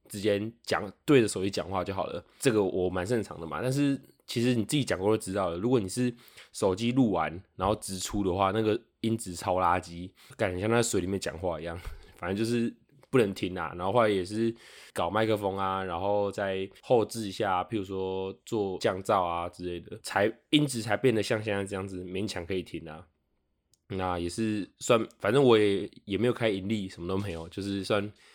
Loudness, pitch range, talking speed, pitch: -29 LUFS, 90-110 Hz, 300 characters per minute, 100 Hz